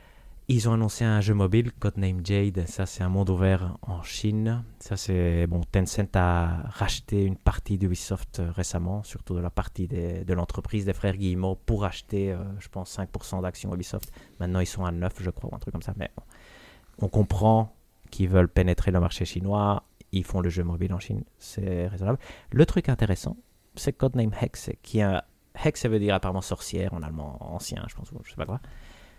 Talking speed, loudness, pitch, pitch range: 200 wpm, -28 LUFS, 95 Hz, 90-105 Hz